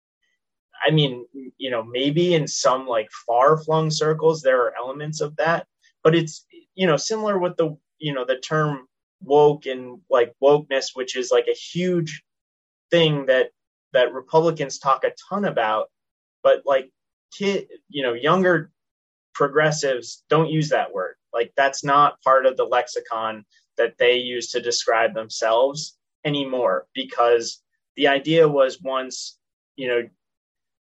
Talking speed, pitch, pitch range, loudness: 145 wpm, 150 Hz, 130-175 Hz, -21 LUFS